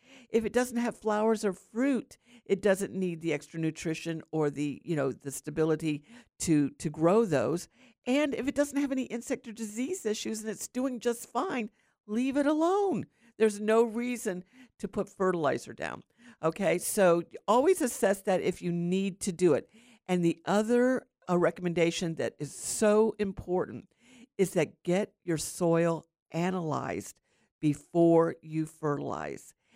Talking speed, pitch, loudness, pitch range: 155 wpm, 195 Hz, -30 LUFS, 165-235 Hz